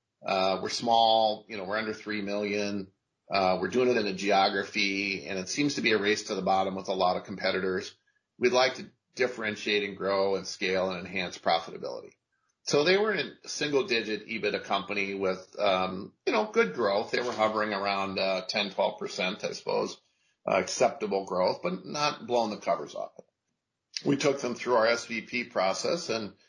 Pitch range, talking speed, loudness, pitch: 95-115 Hz, 190 wpm, -28 LUFS, 105 Hz